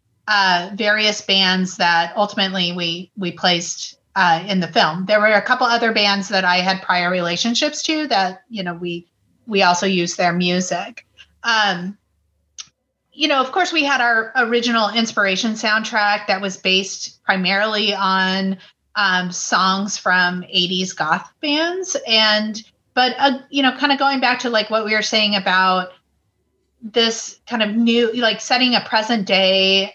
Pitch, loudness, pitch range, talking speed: 205 Hz, -17 LUFS, 185-230 Hz, 160 wpm